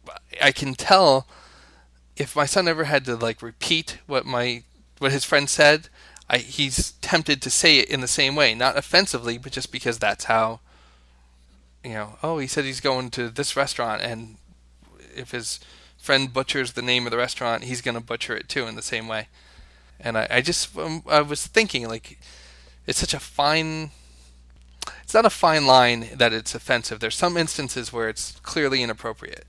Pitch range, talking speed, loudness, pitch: 110-140 Hz, 185 wpm, -21 LUFS, 125 Hz